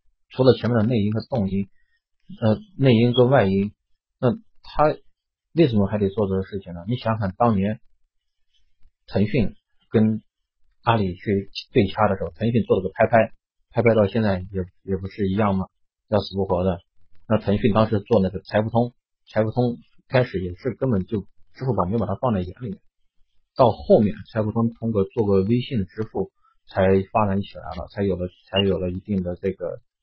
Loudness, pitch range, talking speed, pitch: -22 LUFS, 95-115 Hz, 265 characters per minute, 100 Hz